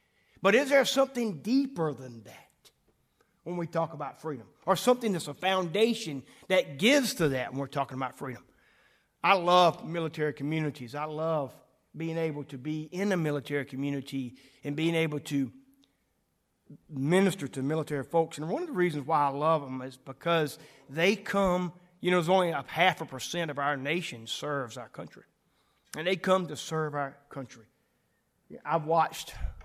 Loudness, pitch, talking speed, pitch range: -29 LUFS, 155 Hz, 170 wpm, 140-180 Hz